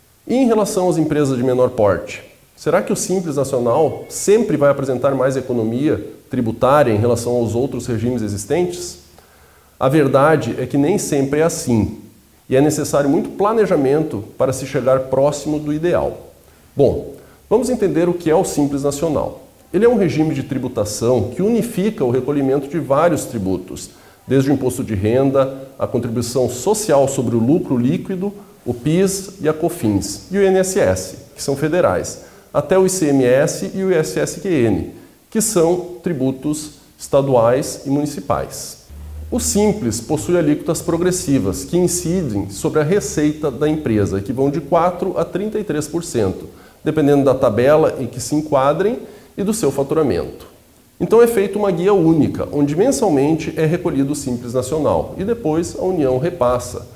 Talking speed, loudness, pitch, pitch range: 155 wpm, -17 LUFS, 145 Hz, 125-175 Hz